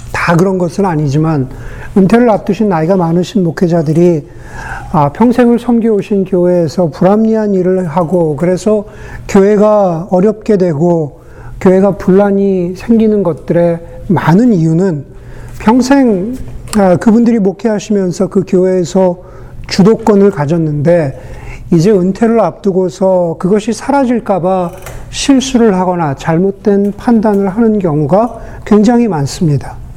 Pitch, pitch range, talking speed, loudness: 185 Hz, 170-210 Hz, 280 characters per minute, -10 LUFS